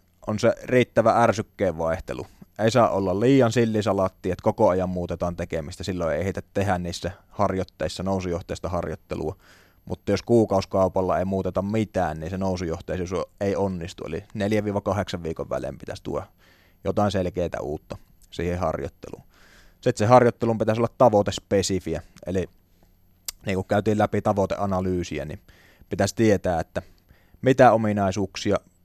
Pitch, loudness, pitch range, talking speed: 95 Hz, -24 LUFS, 90-100 Hz, 130 wpm